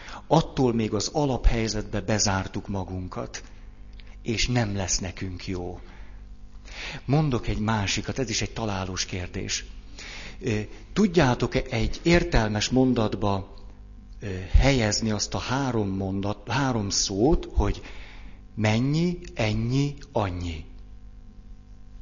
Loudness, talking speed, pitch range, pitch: -26 LUFS, 95 wpm, 95-115 Hz, 105 Hz